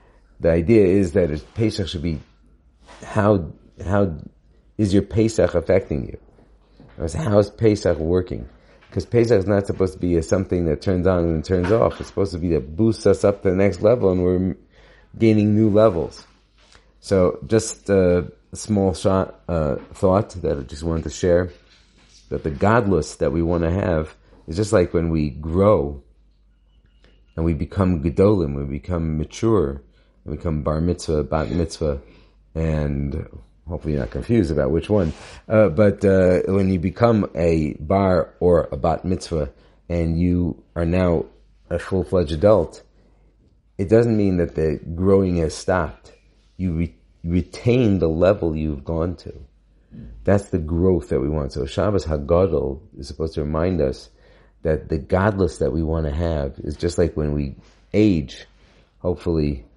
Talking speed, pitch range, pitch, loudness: 165 wpm, 80-100 Hz, 85 Hz, -21 LUFS